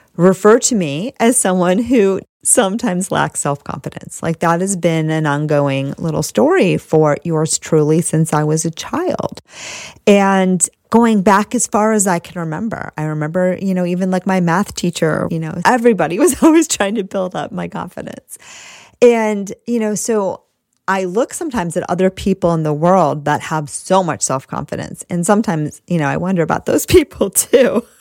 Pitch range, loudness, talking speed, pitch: 160-205 Hz, -15 LUFS, 180 wpm, 180 Hz